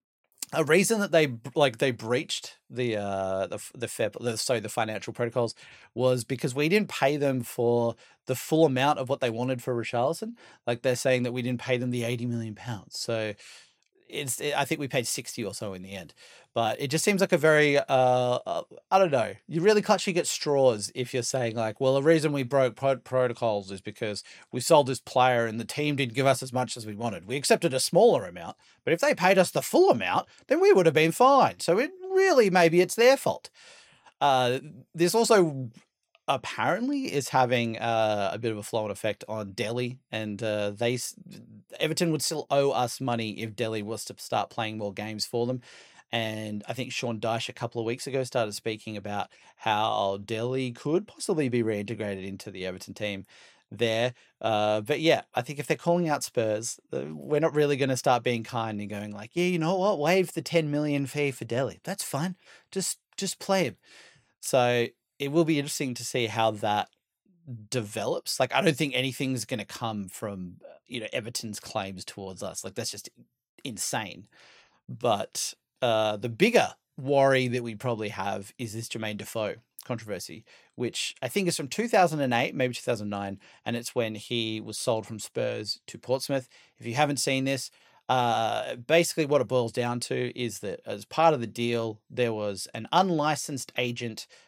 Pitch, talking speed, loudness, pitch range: 125 Hz, 195 wpm, -27 LUFS, 110-145 Hz